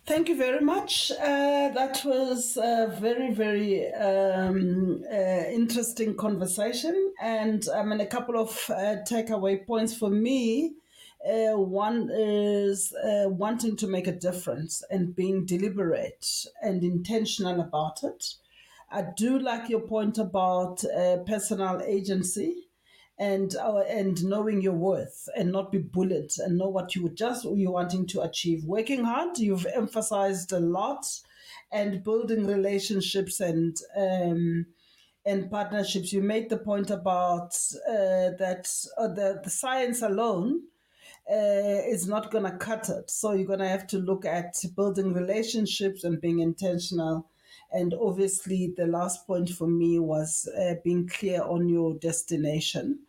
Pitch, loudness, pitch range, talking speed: 200 Hz, -28 LUFS, 180-225 Hz, 145 wpm